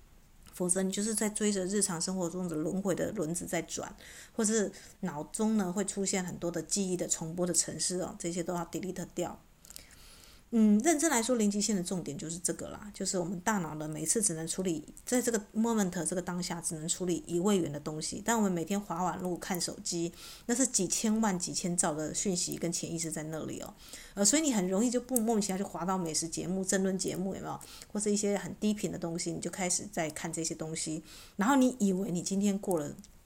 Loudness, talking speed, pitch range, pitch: -32 LUFS, 345 characters per minute, 170-205 Hz, 185 Hz